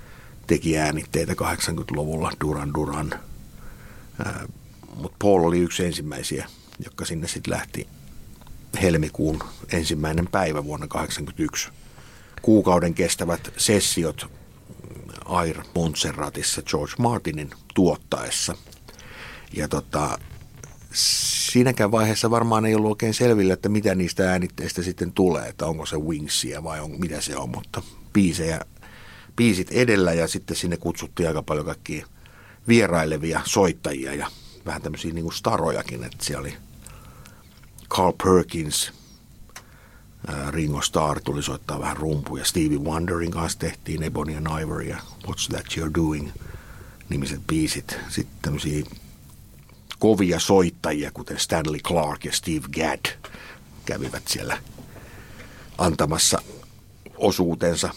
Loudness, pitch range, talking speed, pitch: -24 LUFS, 75-105 Hz, 115 wpm, 85 Hz